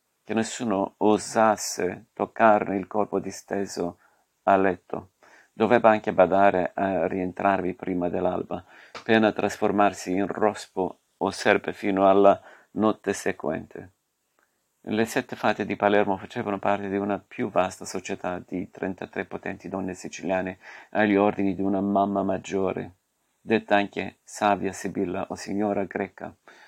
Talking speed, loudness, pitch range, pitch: 125 wpm, -25 LUFS, 95-105 Hz, 100 Hz